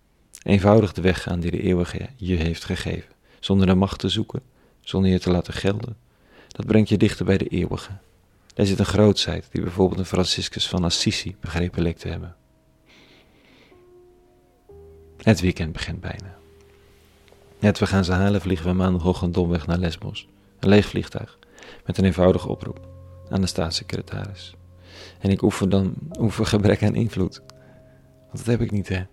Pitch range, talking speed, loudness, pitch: 90-105 Hz, 170 wpm, -22 LUFS, 95 Hz